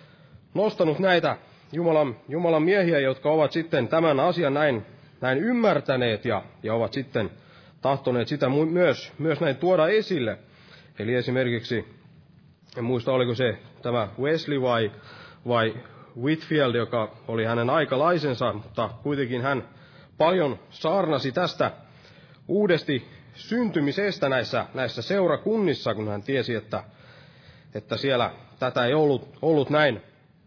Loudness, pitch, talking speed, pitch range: -25 LUFS, 140 Hz, 120 wpm, 120-160 Hz